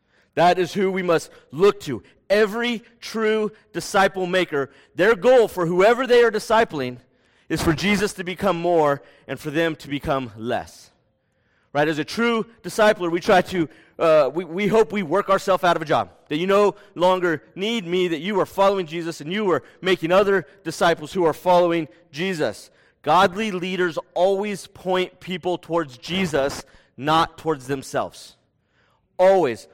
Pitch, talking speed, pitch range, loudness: 180 Hz, 165 wpm, 160-200 Hz, -21 LUFS